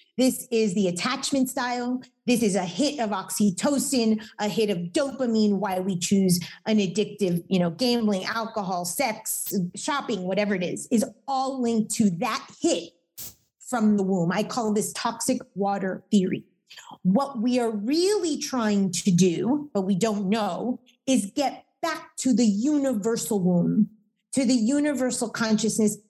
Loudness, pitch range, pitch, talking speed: -25 LUFS, 200-255 Hz, 220 Hz, 150 wpm